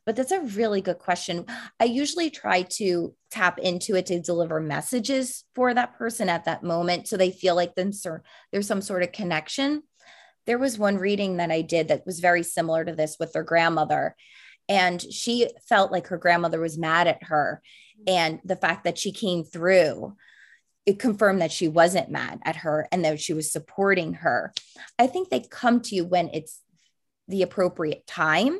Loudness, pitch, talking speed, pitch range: -25 LUFS, 180 Hz, 185 wpm, 170-220 Hz